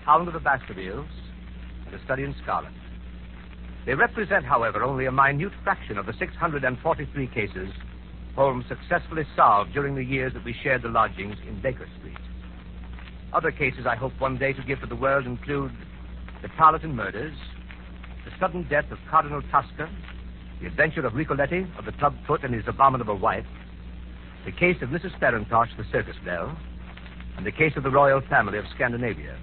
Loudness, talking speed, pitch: -25 LUFS, 175 wpm, 120 Hz